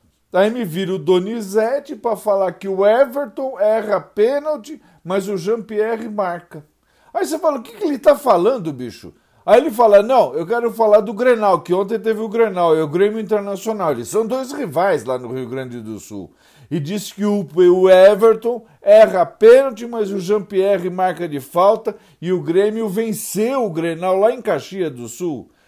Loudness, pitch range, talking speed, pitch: -17 LUFS, 180-230 Hz, 180 wpm, 205 Hz